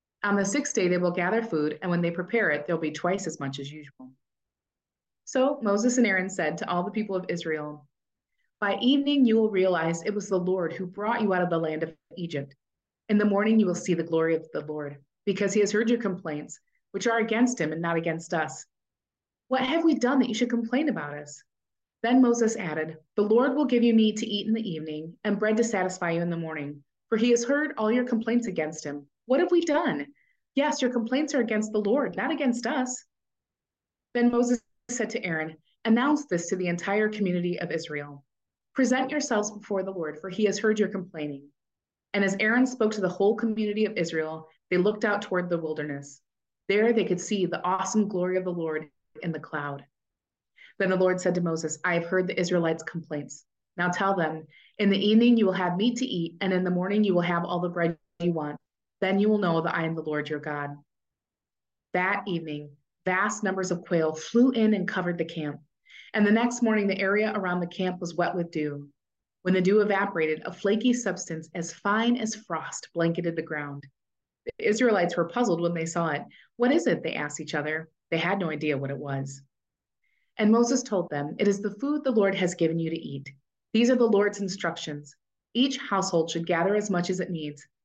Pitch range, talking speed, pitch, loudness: 160-220 Hz, 220 wpm, 185 Hz, -27 LUFS